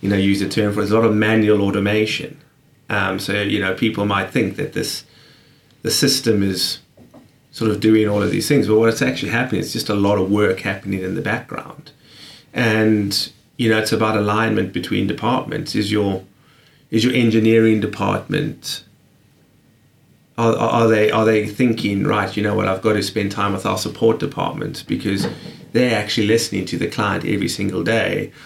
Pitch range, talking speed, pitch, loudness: 100-115 Hz, 185 wpm, 110 Hz, -18 LUFS